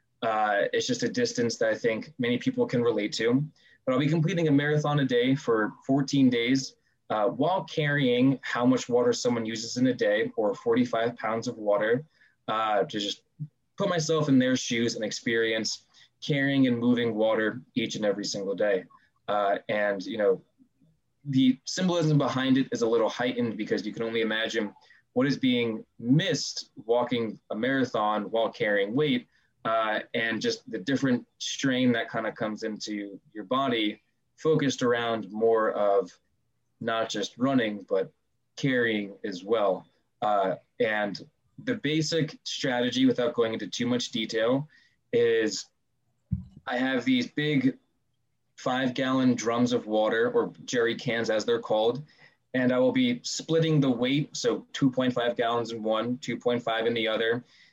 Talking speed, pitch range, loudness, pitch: 160 wpm, 115-155 Hz, -27 LUFS, 125 Hz